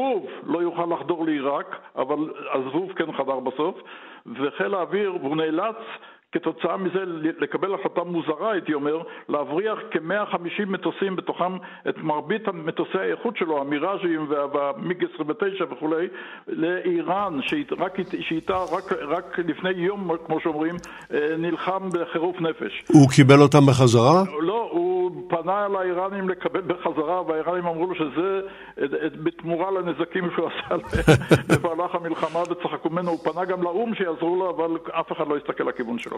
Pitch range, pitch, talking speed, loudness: 160-185 Hz, 170 Hz, 130 wpm, -24 LUFS